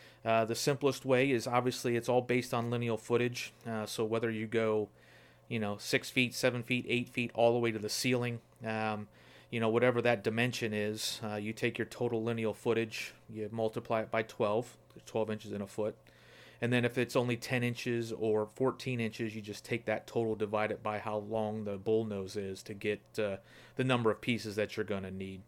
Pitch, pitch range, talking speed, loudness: 115 Hz, 105-120 Hz, 210 wpm, -34 LUFS